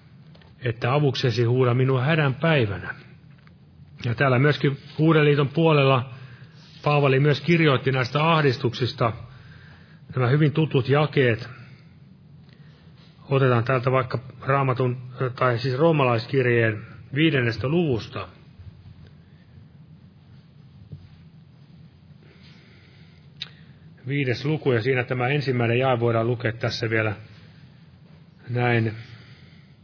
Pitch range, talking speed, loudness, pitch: 125-150 Hz, 80 wpm, -22 LUFS, 135 Hz